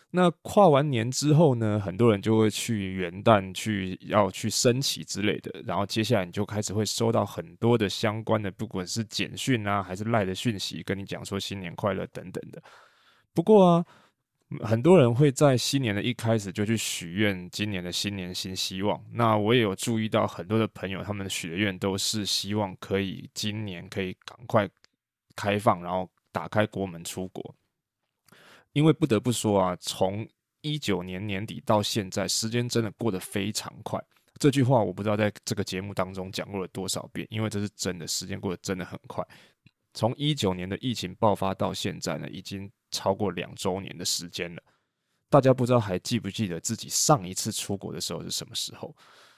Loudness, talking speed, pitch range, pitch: -27 LUFS, 290 characters per minute, 95-115 Hz, 105 Hz